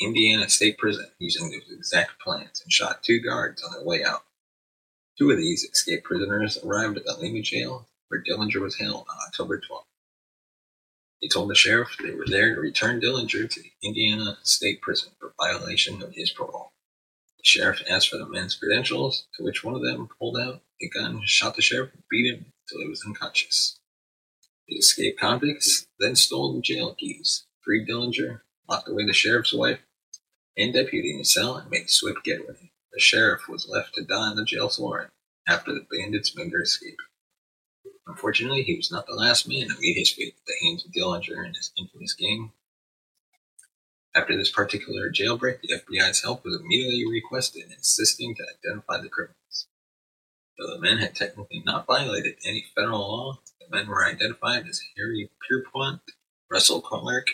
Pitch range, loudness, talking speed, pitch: 105-135 Hz, -23 LUFS, 180 wpm, 115 Hz